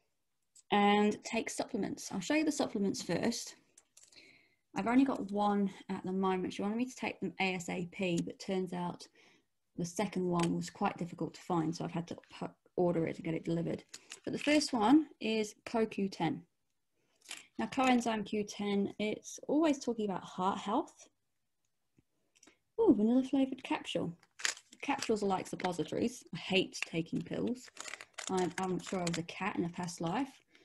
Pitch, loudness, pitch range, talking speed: 200 Hz, -35 LUFS, 175-240 Hz, 165 wpm